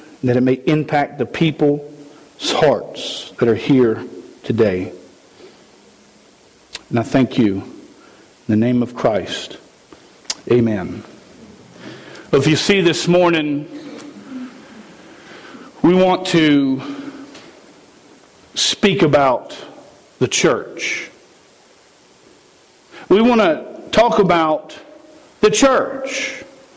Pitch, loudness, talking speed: 155 Hz, -16 LUFS, 90 wpm